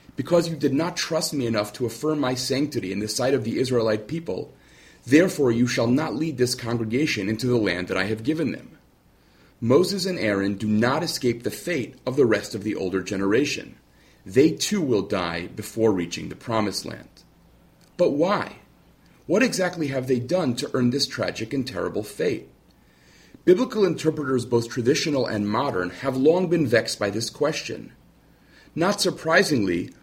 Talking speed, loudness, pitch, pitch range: 170 wpm, -23 LUFS, 125 Hz, 110-155 Hz